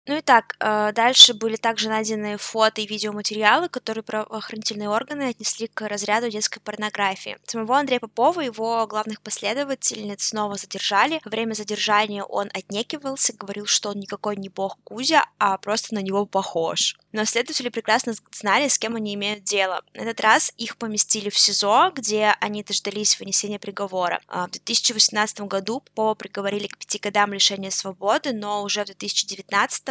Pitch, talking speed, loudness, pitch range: 215 Hz, 160 wpm, -21 LUFS, 205-230 Hz